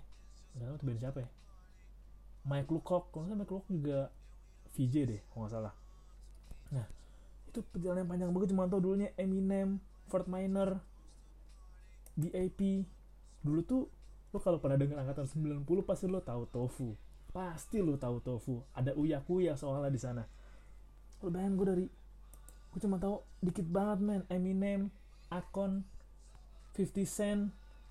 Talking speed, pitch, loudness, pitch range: 140 wpm, 180 Hz, -37 LUFS, 135-195 Hz